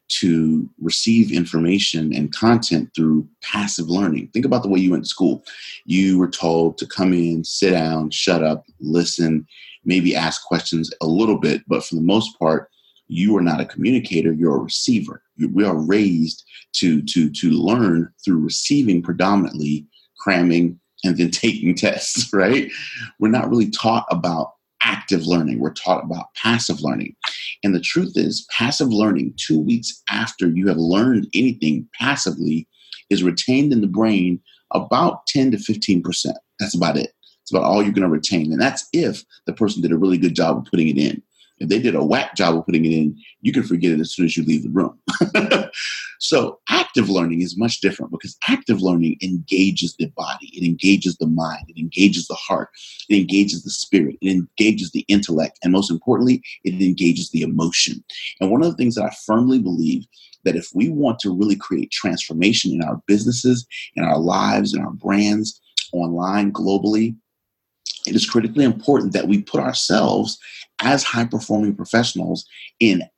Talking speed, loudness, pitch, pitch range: 180 wpm, -19 LUFS, 90 Hz, 85-105 Hz